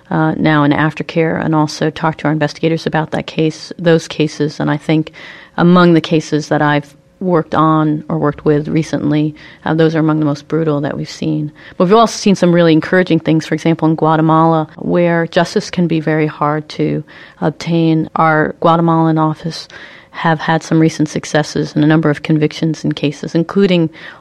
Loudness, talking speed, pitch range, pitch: -14 LUFS, 185 wpm, 150-165 Hz, 160 Hz